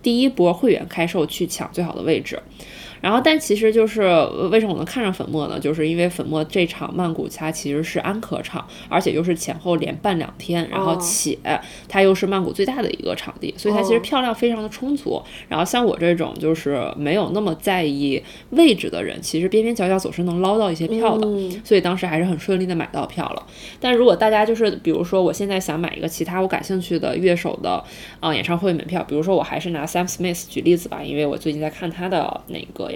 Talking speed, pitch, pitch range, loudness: 355 characters per minute, 175 Hz, 165-205 Hz, -20 LUFS